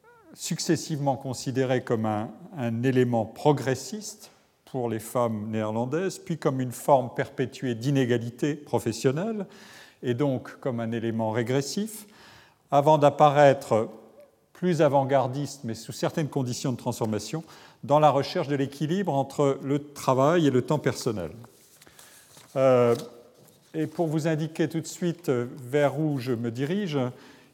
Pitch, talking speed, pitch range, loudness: 140 Hz, 130 wpm, 125-160 Hz, -26 LUFS